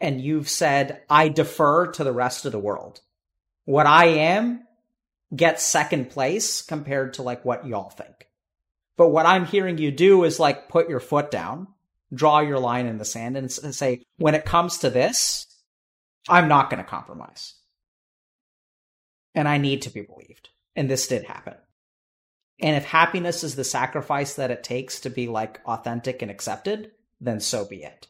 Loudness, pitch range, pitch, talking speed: -22 LUFS, 120-165 Hz, 140 Hz, 175 wpm